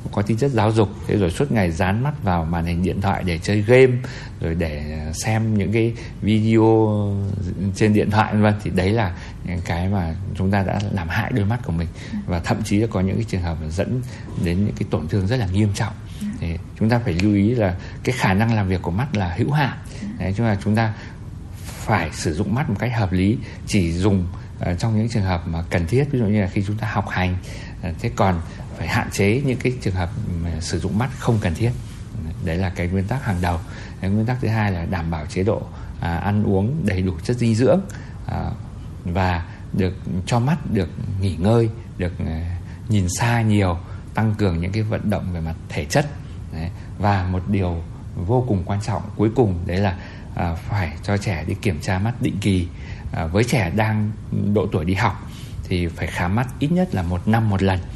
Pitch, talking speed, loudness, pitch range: 100 Hz, 215 wpm, -21 LUFS, 90-110 Hz